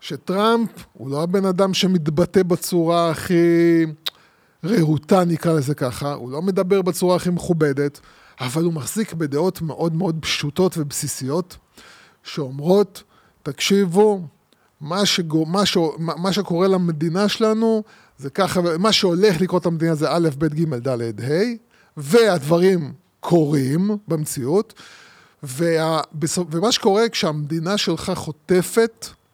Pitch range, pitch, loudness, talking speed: 155-195 Hz, 170 Hz, -20 LUFS, 120 wpm